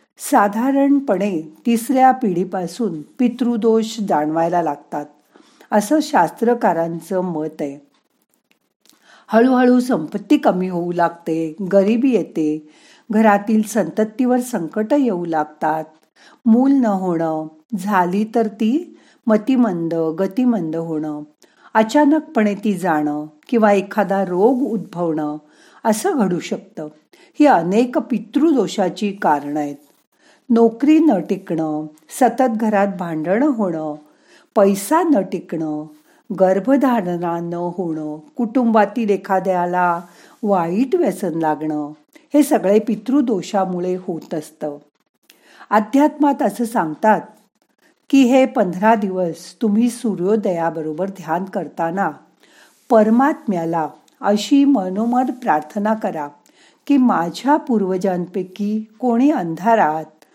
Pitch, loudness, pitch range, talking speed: 205 Hz, -18 LUFS, 170-245 Hz, 90 wpm